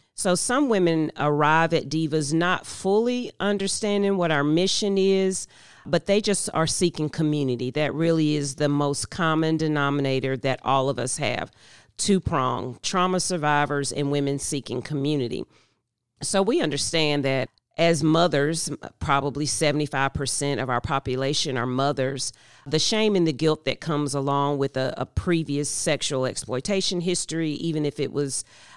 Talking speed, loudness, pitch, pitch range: 150 wpm, -24 LUFS, 150 Hz, 135-170 Hz